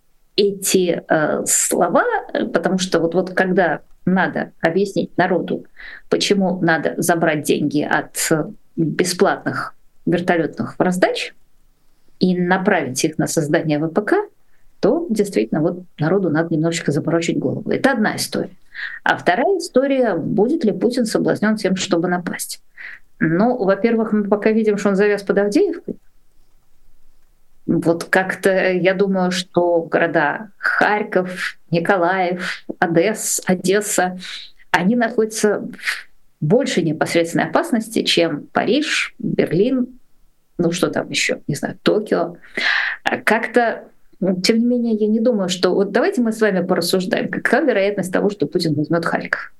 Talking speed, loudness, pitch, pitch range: 125 wpm, -18 LUFS, 185 Hz, 170-215 Hz